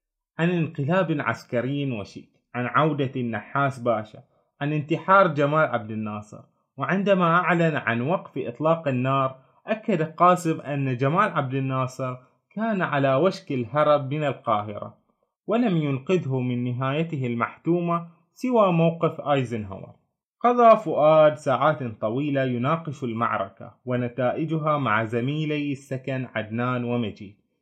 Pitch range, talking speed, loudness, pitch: 125-165 Hz, 110 wpm, -24 LUFS, 140 Hz